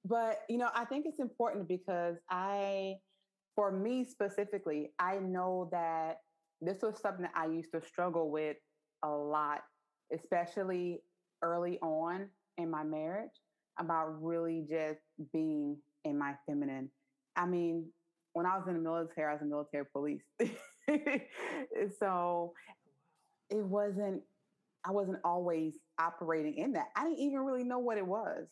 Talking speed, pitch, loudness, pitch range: 145 wpm, 175 Hz, -37 LUFS, 160-200 Hz